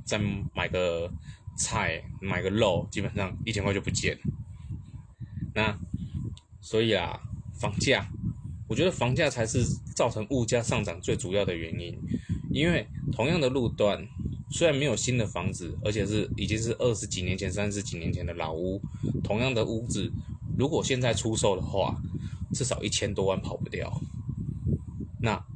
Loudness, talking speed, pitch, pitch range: -29 LUFS, 230 characters per minute, 105 Hz, 95-120 Hz